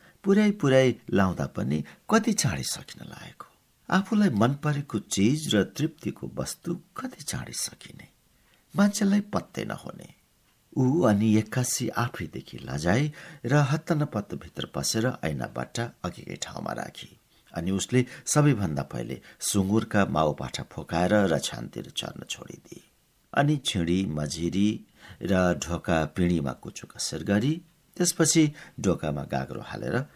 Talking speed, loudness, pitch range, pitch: 110 wpm, -27 LUFS, 95-155 Hz, 120 Hz